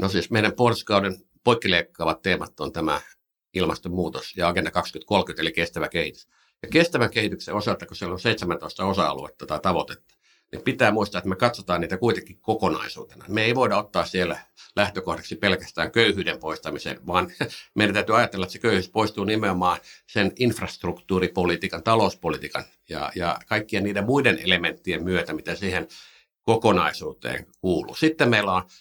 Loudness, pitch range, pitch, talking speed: -24 LUFS, 90-110 Hz, 100 Hz, 145 wpm